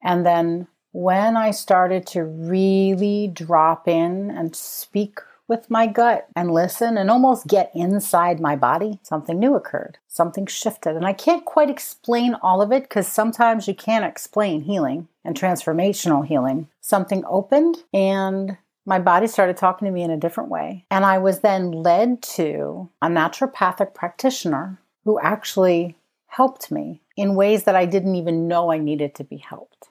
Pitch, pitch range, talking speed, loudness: 195 Hz, 175-220 Hz, 165 wpm, -20 LUFS